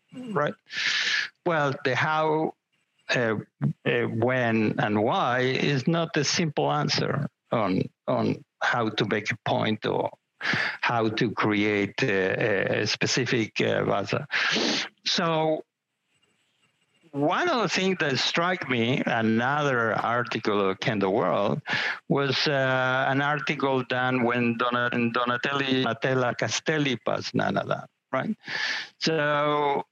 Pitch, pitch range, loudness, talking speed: 130 Hz, 120-150 Hz, -25 LUFS, 115 wpm